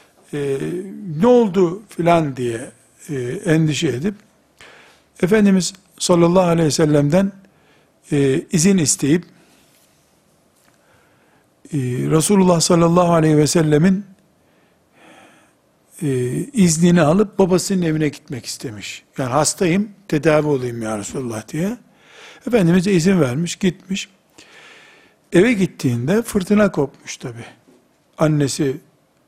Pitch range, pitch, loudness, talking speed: 150-195 Hz, 170 Hz, -17 LUFS, 95 wpm